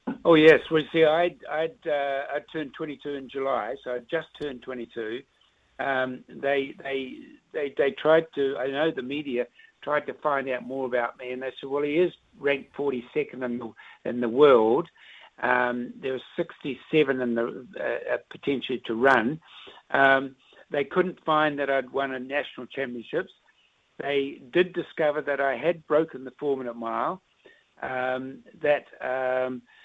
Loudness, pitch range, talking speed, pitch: -26 LUFS, 130-155 Hz, 170 wpm, 140 Hz